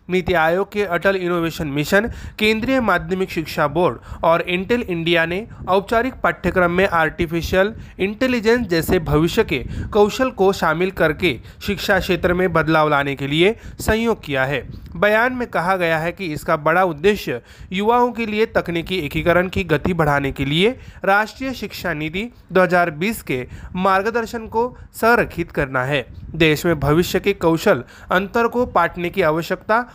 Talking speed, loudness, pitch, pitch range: 150 wpm, -19 LUFS, 180 Hz, 160-205 Hz